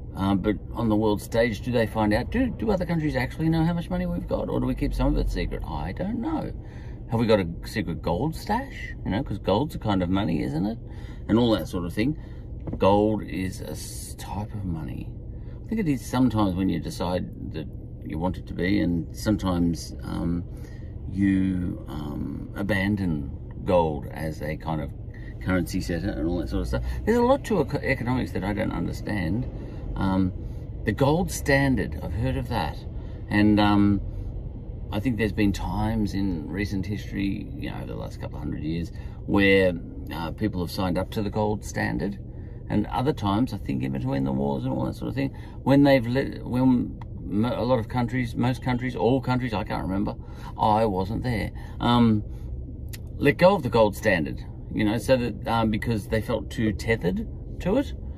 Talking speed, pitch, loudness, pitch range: 195 wpm, 105 Hz, -26 LUFS, 95-120 Hz